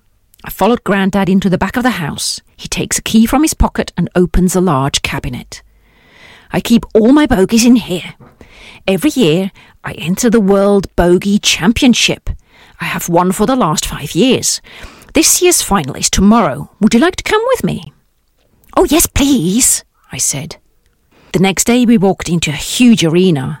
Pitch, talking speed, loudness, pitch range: 195 Hz, 180 wpm, -12 LUFS, 175-235 Hz